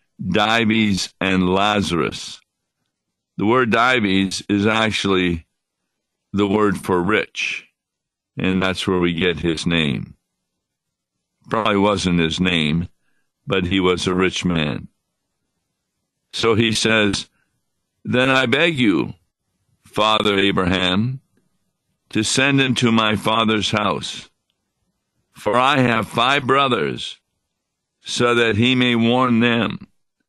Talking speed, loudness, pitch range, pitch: 110 wpm, -18 LUFS, 95-115 Hz, 105 Hz